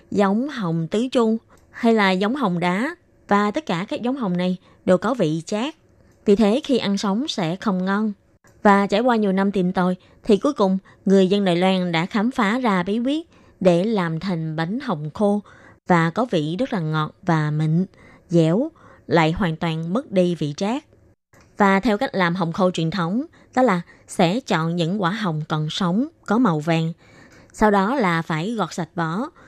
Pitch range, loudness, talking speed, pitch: 170-220 Hz, -21 LUFS, 195 wpm, 195 Hz